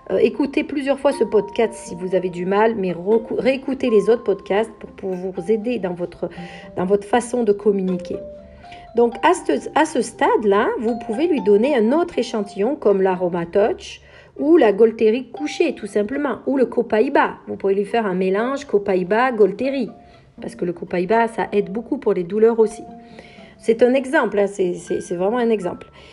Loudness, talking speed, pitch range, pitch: -19 LUFS, 185 wpm, 195-245 Hz, 220 Hz